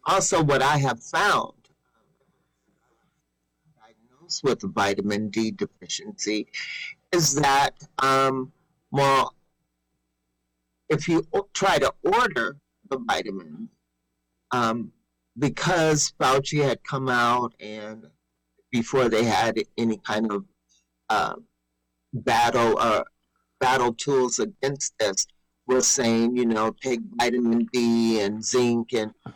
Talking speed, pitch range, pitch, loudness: 105 wpm, 100-135 Hz, 115 Hz, -24 LUFS